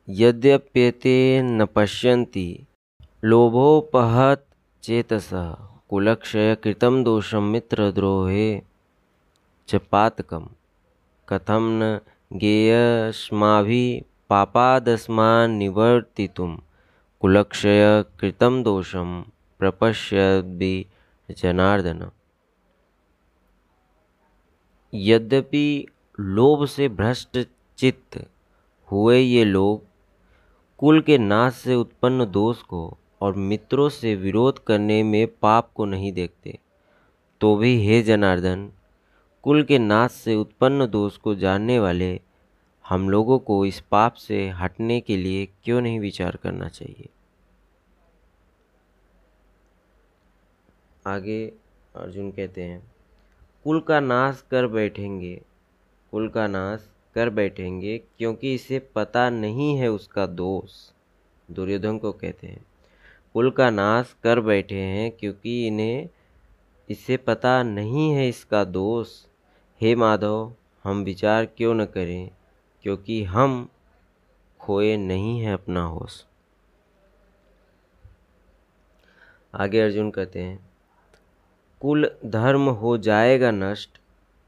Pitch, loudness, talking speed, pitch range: 105 Hz, -21 LUFS, 90 wpm, 95-115 Hz